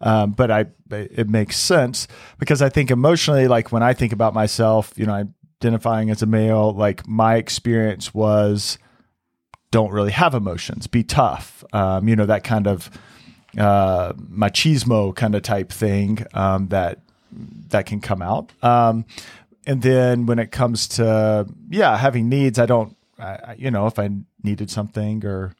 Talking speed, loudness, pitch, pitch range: 165 wpm, -19 LUFS, 110 Hz, 105-120 Hz